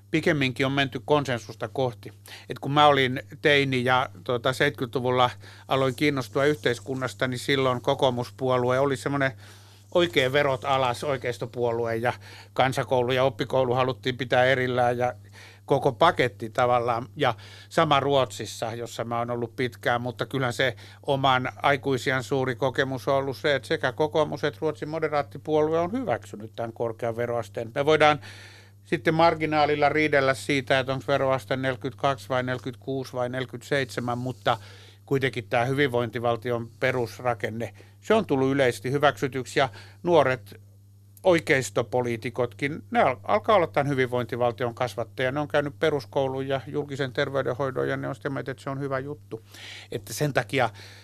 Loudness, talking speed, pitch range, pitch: -25 LUFS, 140 wpm, 120-140 Hz, 130 Hz